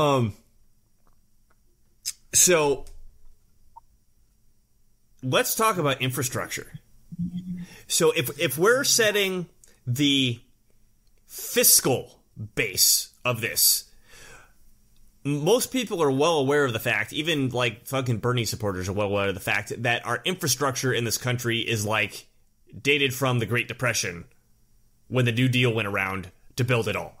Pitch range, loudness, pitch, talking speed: 110-145 Hz, -23 LUFS, 120 Hz, 130 wpm